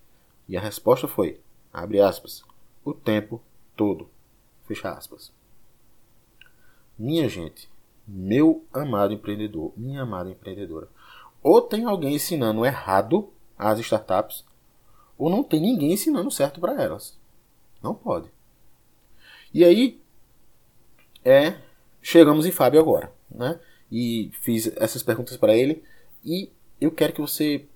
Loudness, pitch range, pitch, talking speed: -22 LUFS, 105-160 Hz, 120 Hz, 120 wpm